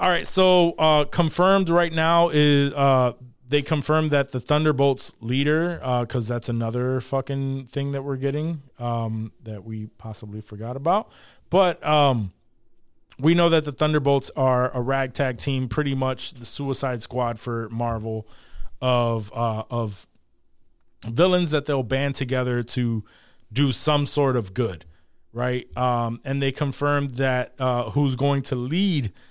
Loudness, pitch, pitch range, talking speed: -23 LUFS, 130 Hz, 115-145 Hz, 150 wpm